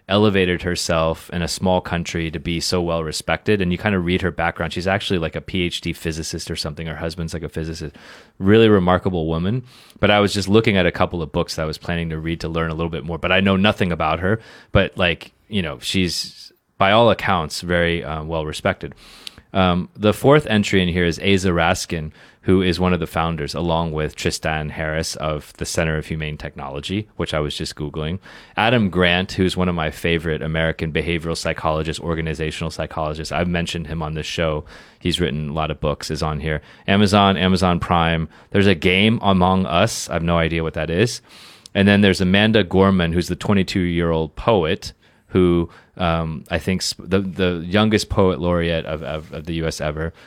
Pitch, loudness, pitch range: 85 Hz, -20 LUFS, 80-95 Hz